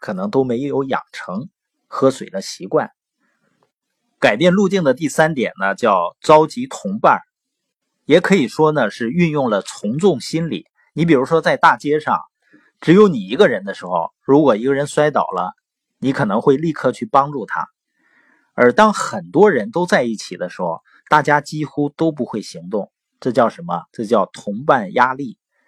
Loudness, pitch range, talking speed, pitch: -17 LUFS, 140-180 Hz, 245 characters per minute, 155 Hz